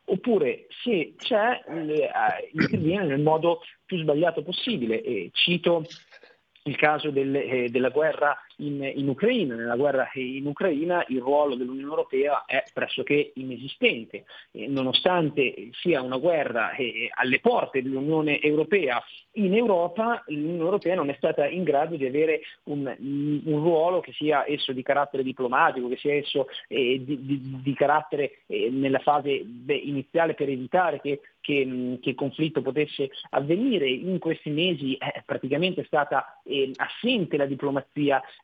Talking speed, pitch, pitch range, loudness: 150 wpm, 145 Hz, 135-170 Hz, -25 LUFS